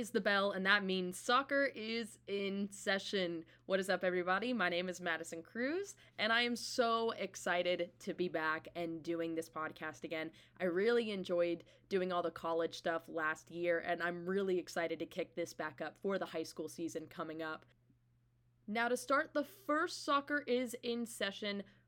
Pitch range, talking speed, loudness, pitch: 165-220 Hz, 180 wpm, -38 LUFS, 180 Hz